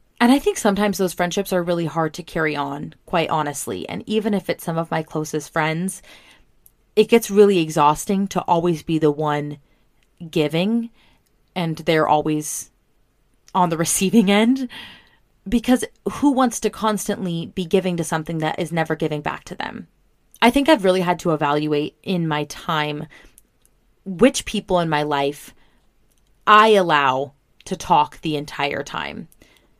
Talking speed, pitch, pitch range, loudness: 155 wpm, 175 Hz, 155-200 Hz, -20 LUFS